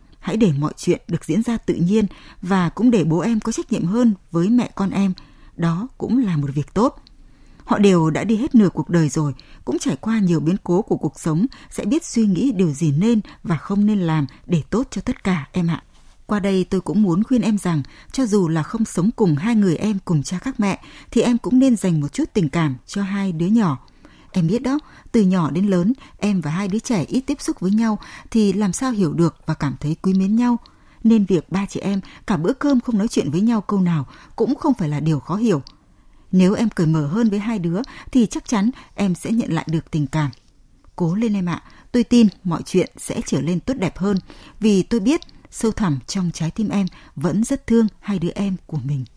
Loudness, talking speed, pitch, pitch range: -20 LUFS, 240 wpm, 195 Hz, 165-225 Hz